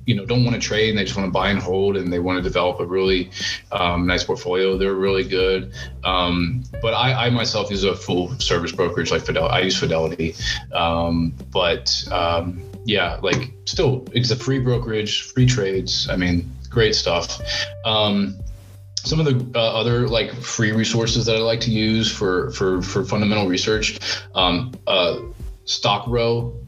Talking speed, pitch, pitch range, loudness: 180 wpm, 100 Hz, 90-115 Hz, -20 LUFS